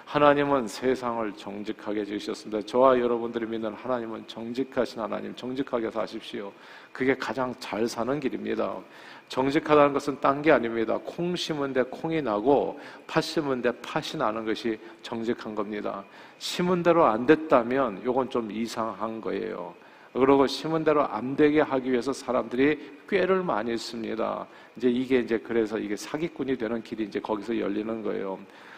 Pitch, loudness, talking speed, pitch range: 120 Hz, -27 LUFS, 345 characters per minute, 110-140 Hz